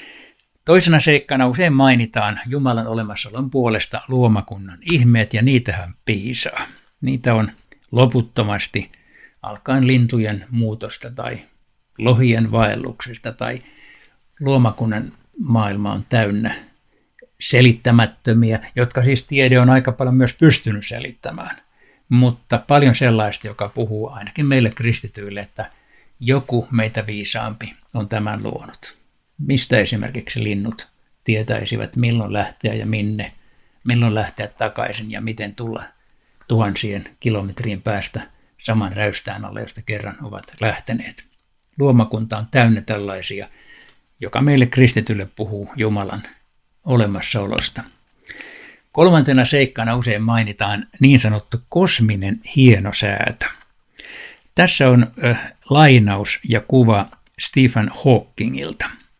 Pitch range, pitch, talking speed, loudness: 105-125 Hz, 115 Hz, 100 wpm, -17 LUFS